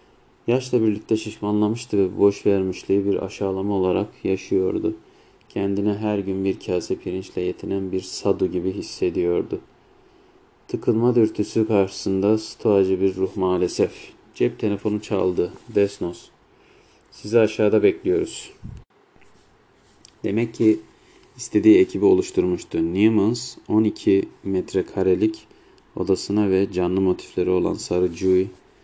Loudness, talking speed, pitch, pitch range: -22 LUFS, 105 wpm, 105 Hz, 95-125 Hz